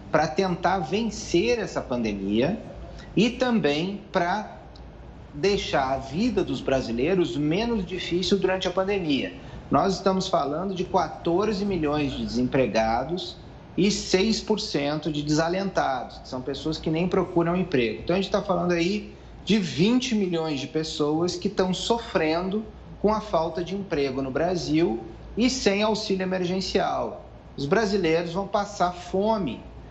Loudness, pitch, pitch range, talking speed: -25 LUFS, 180 Hz, 155-200 Hz, 135 wpm